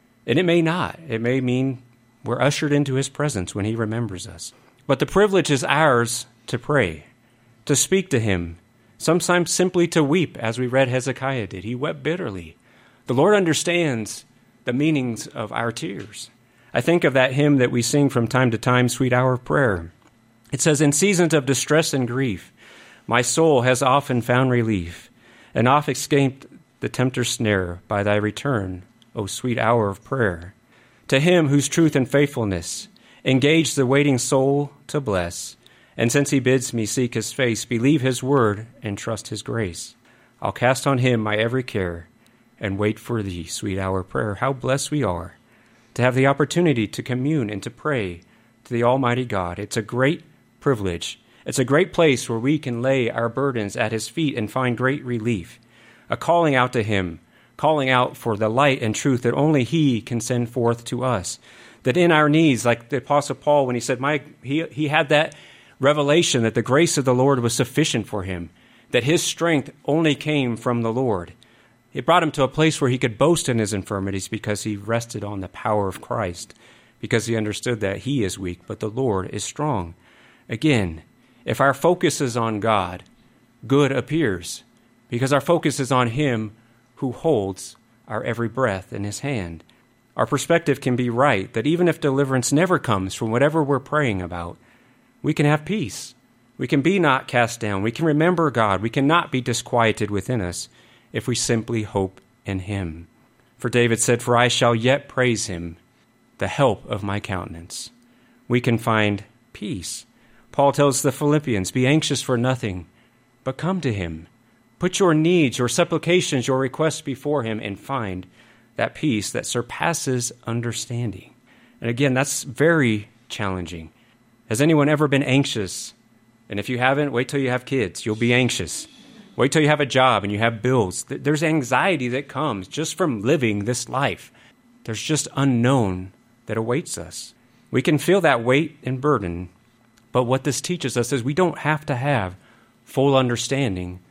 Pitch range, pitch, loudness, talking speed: 110-140 Hz, 125 Hz, -21 LUFS, 180 wpm